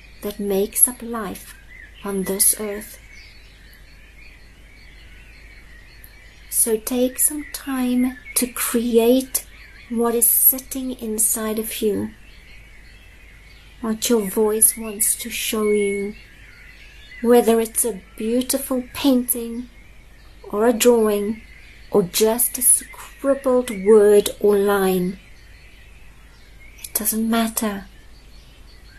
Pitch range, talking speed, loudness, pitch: 205-245 Hz, 90 wpm, -19 LUFS, 220 Hz